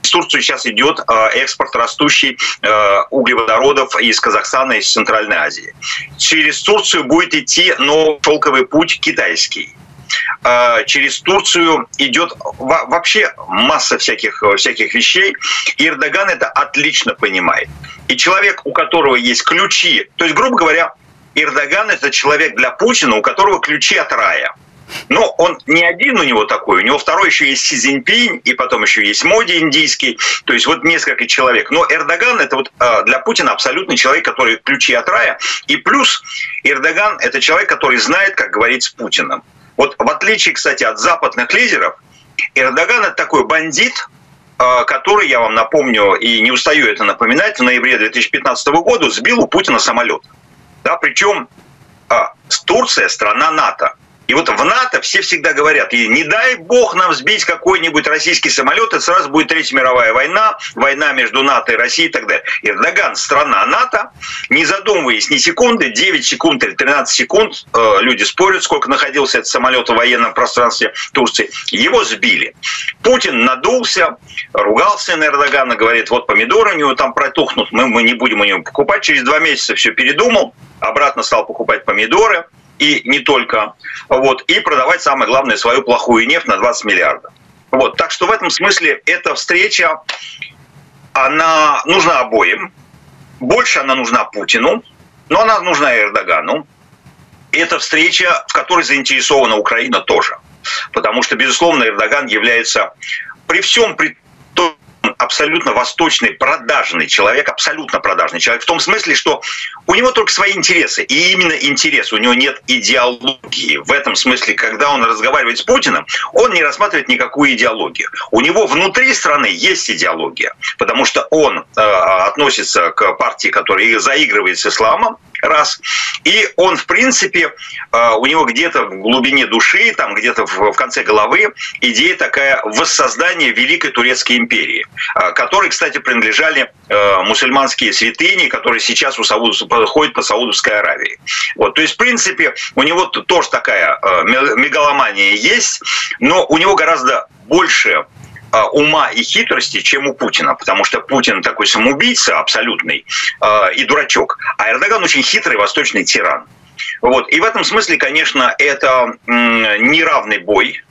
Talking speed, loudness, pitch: 150 wpm, -11 LUFS, 185 Hz